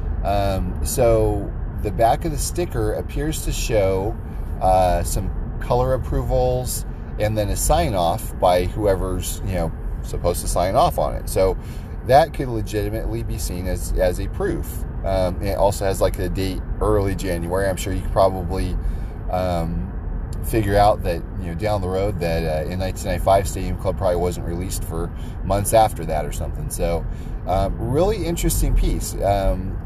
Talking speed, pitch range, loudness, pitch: 165 wpm, 85-105 Hz, -22 LUFS, 95 Hz